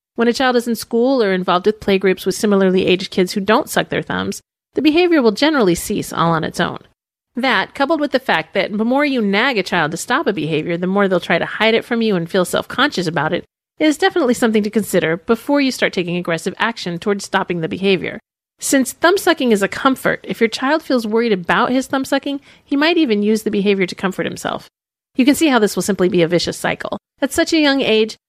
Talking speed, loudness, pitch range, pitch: 240 wpm, -17 LUFS, 190-265 Hz, 220 Hz